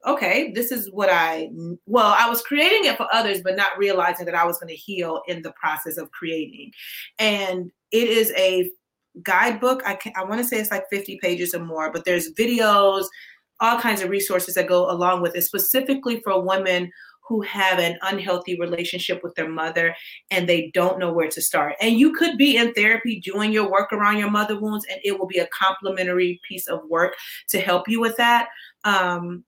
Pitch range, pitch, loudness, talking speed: 175-215 Hz, 190 Hz, -21 LUFS, 200 wpm